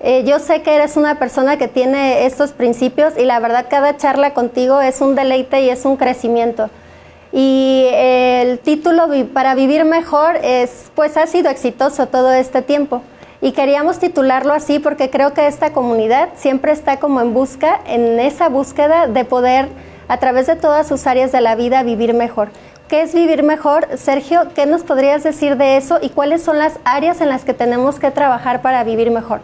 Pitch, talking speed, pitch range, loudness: 275 Hz, 190 wpm, 255-295 Hz, -14 LUFS